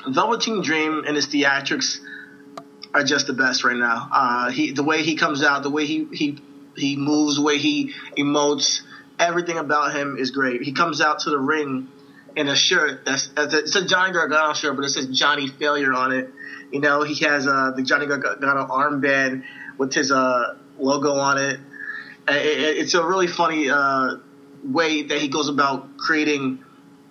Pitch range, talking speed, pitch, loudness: 140-155 Hz, 180 wpm, 145 Hz, -20 LUFS